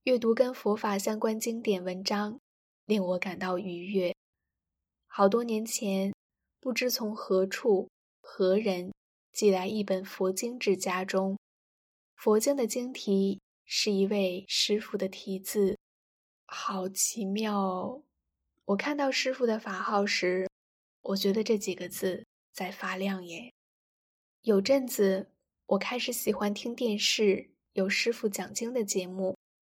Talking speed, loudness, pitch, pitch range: 190 characters per minute, -30 LUFS, 200 Hz, 190-225 Hz